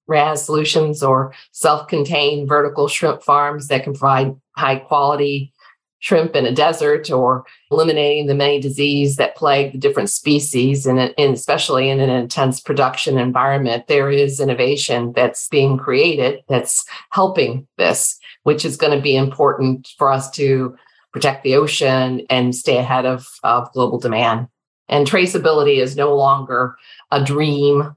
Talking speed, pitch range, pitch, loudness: 150 wpm, 130-145 Hz, 140 Hz, -16 LUFS